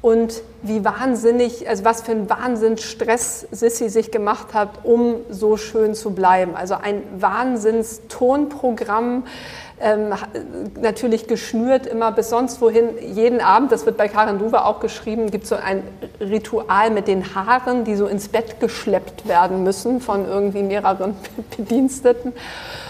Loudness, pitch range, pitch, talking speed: -19 LUFS, 210-235 Hz, 225 Hz, 145 wpm